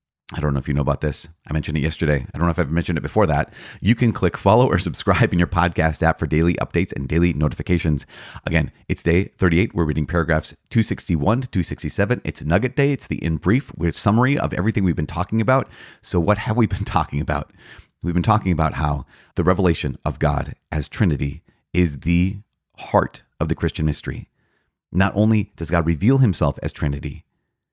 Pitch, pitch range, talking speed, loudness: 85 Hz, 75-100 Hz, 205 wpm, -21 LUFS